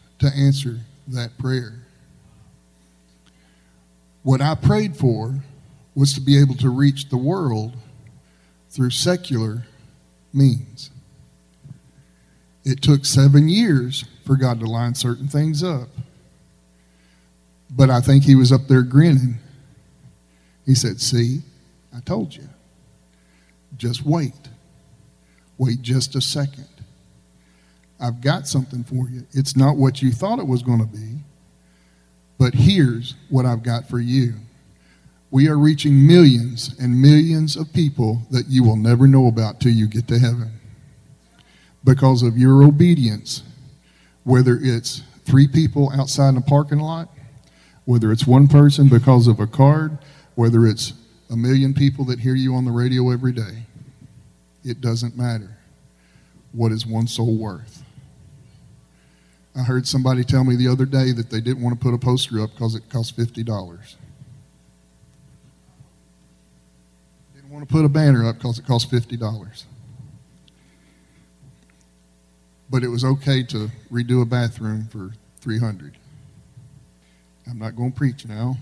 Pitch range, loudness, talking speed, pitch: 110-135 Hz, -18 LUFS, 140 wpm, 125 Hz